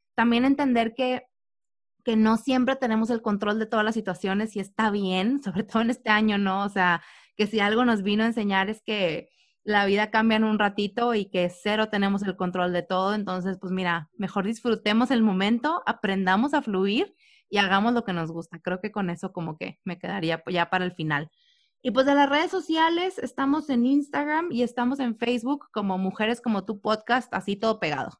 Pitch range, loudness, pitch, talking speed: 190-245 Hz, -25 LUFS, 215 Hz, 205 wpm